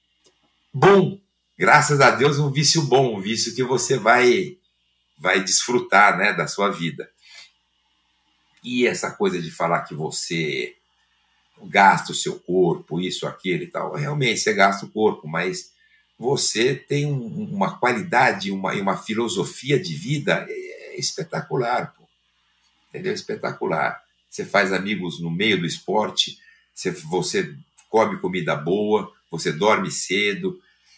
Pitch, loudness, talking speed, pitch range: 160 Hz, -21 LUFS, 130 wpm, 125-195 Hz